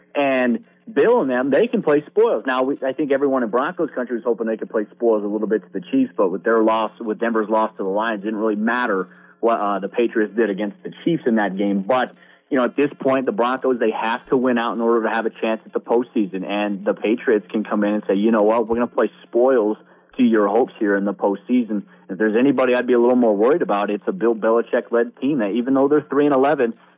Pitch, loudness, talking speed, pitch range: 115 Hz, -20 LUFS, 270 wpm, 110-130 Hz